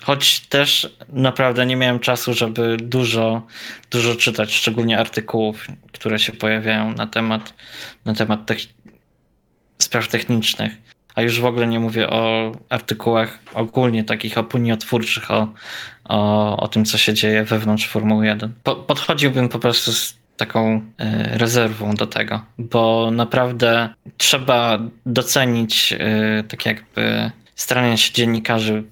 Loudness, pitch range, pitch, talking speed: -18 LUFS, 110-120 Hz, 115 Hz, 130 wpm